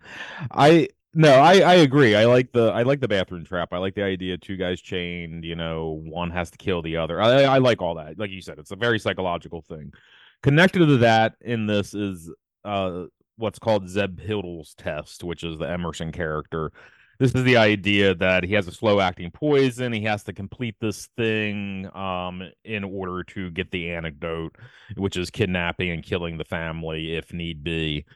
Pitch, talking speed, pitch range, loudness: 95 Hz, 200 wpm, 85-110 Hz, -22 LUFS